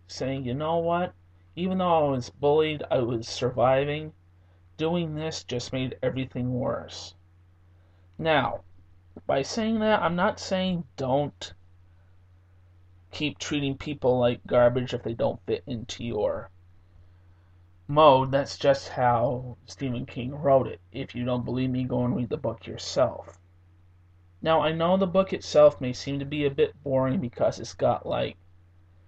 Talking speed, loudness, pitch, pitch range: 150 wpm, -26 LUFS, 125 Hz, 90-145 Hz